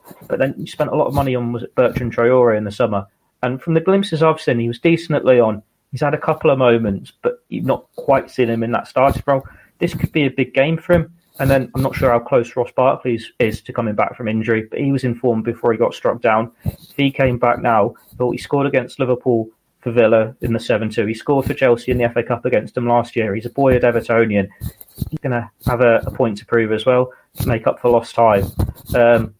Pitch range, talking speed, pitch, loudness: 115-140 Hz, 250 wpm, 125 Hz, -17 LUFS